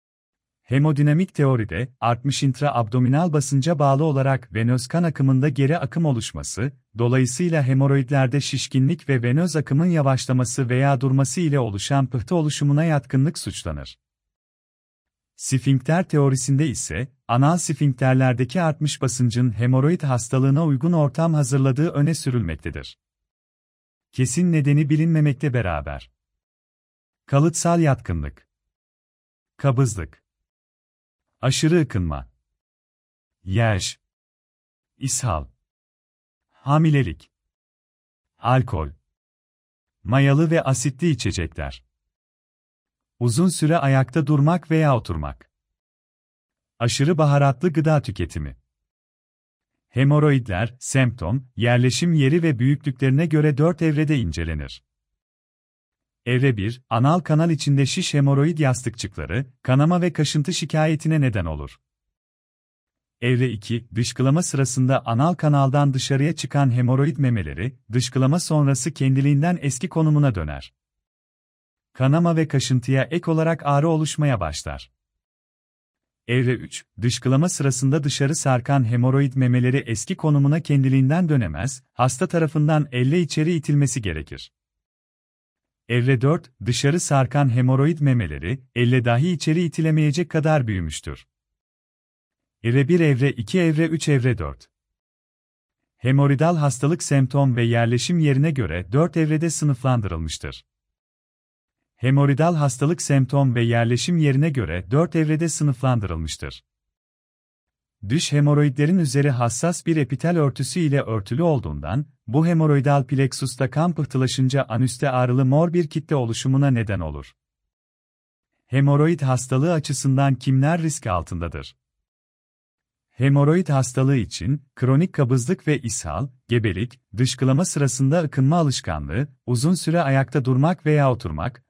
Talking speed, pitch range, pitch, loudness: 100 wpm, 90-150 Hz, 130 Hz, -21 LUFS